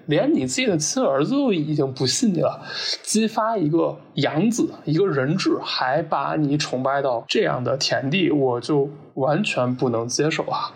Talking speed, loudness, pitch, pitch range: 250 characters per minute, -21 LUFS, 150 Hz, 135-220 Hz